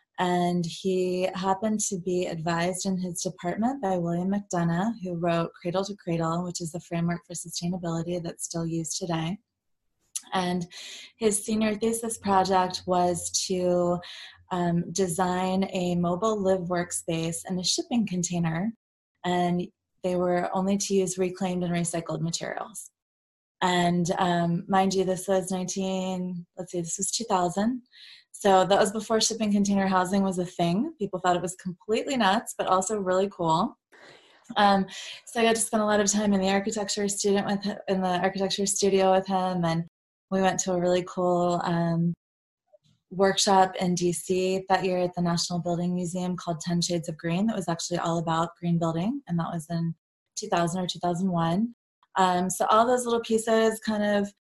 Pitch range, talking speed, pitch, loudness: 175-200 Hz, 175 wpm, 185 Hz, -26 LUFS